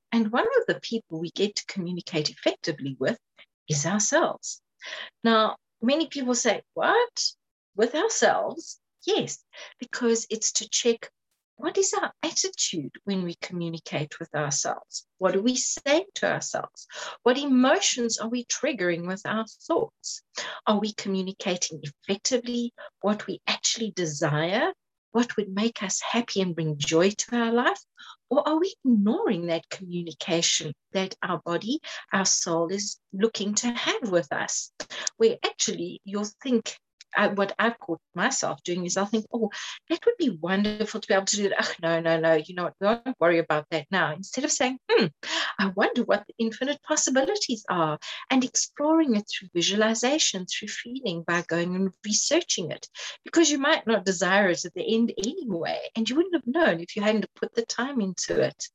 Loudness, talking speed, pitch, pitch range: -26 LUFS, 170 wpm, 215 Hz, 180-255 Hz